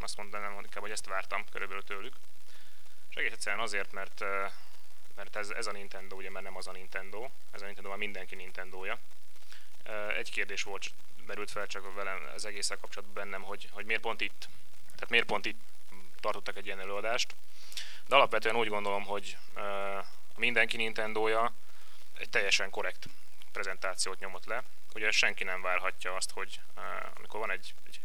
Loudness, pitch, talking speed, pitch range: -34 LUFS, 100 Hz, 165 wpm, 95-105 Hz